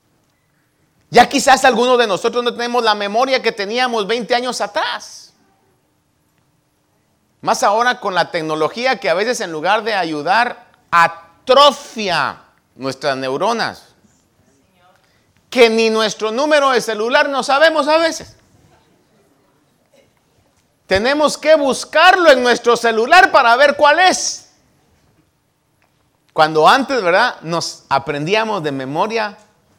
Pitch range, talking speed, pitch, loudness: 170-265 Hz, 115 wpm, 230 Hz, -14 LUFS